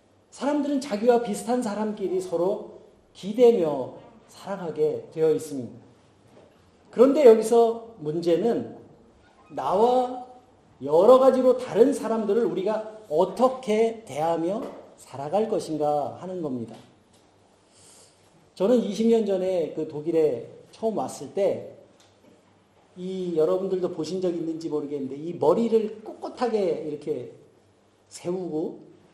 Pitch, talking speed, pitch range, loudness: 205 Hz, 240 characters per minute, 160-240 Hz, -24 LUFS